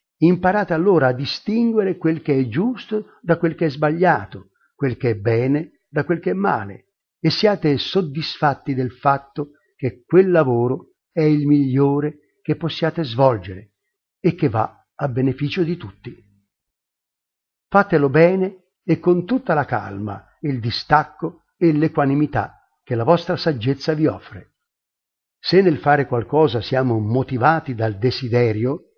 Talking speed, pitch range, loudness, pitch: 140 wpm, 130-170 Hz, -19 LUFS, 150 Hz